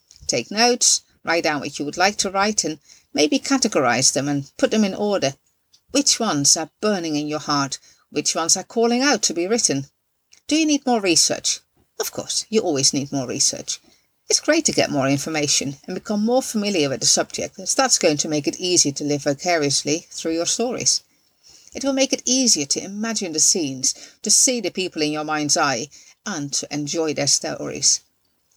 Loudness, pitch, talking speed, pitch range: -19 LUFS, 165 Hz, 195 wpm, 145-220 Hz